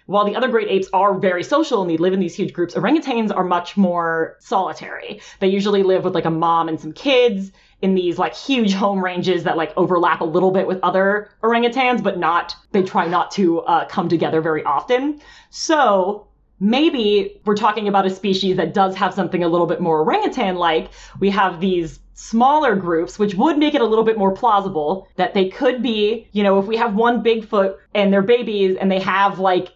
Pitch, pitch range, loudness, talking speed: 195 Hz, 180-220 Hz, -18 LUFS, 210 wpm